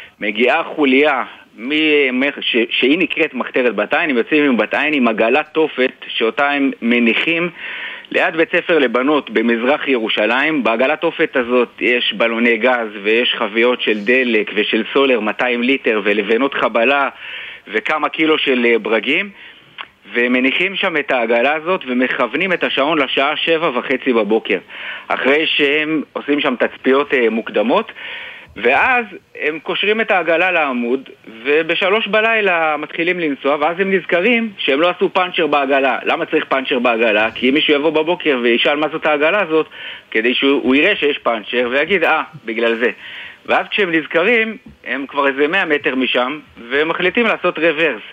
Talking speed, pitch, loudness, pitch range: 145 wpm, 145 Hz, -15 LUFS, 125-165 Hz